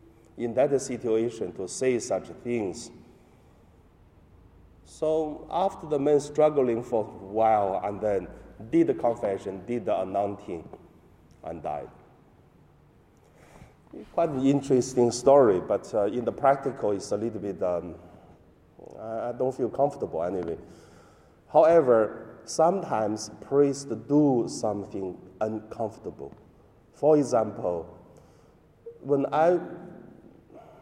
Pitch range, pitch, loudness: 100-140 Hz, 120 Hz, -26 LUFS